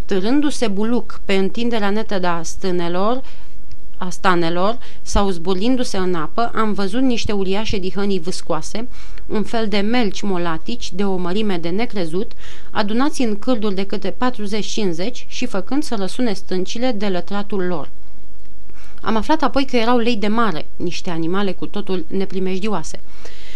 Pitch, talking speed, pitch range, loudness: 200 Hz, 145 wpm, 185-230 Hz, -21 LUFS